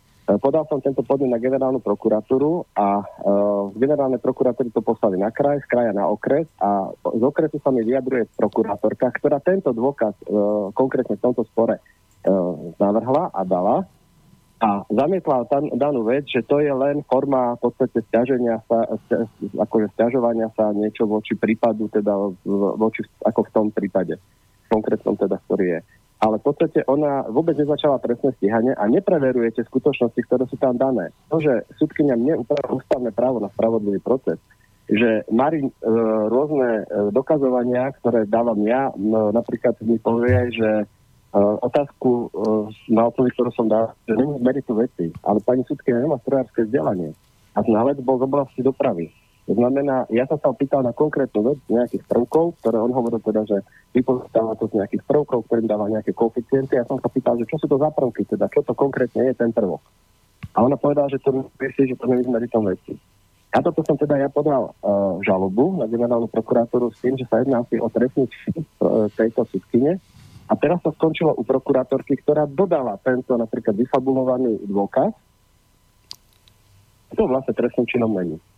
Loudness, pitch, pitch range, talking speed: -21 LUFS, 120 Hz, 110-135 Hz, 175 wpm